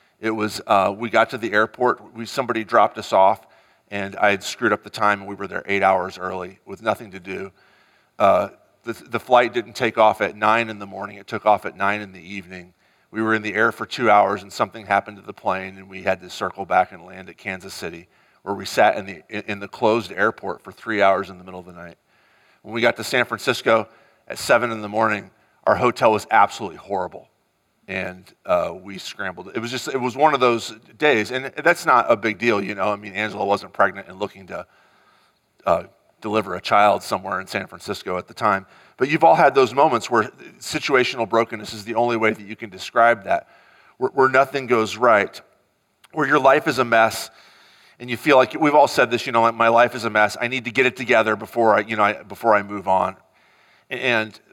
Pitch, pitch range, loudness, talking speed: 110 Hz, 100-120 Hz, -20 LUFS, 235 wpm